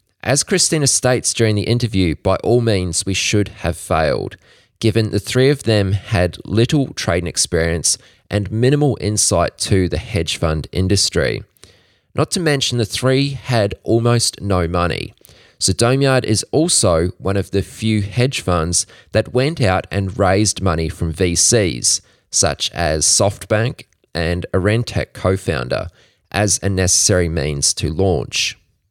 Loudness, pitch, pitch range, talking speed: -17 LUFS, 100 Hz, 90-120 Hz, 145 wpm